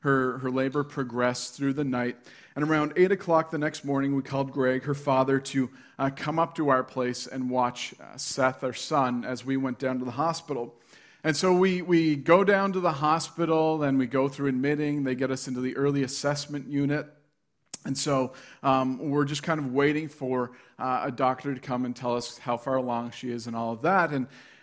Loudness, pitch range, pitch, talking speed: -27 LUFS, 130-150 Hz, 135 Hz, 215 wpm